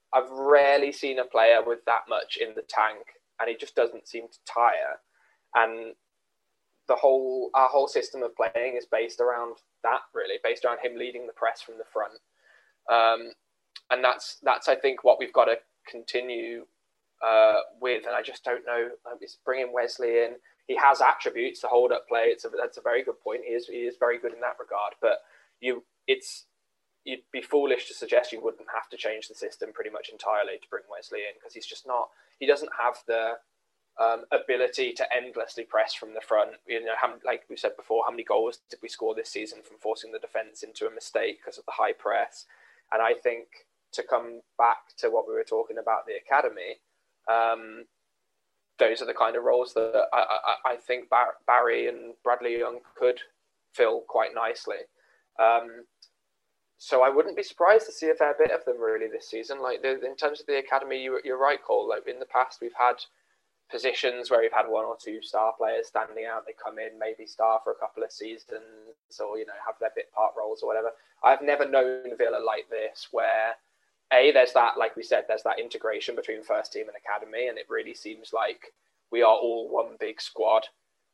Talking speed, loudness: 205 wpm, -27 LUFS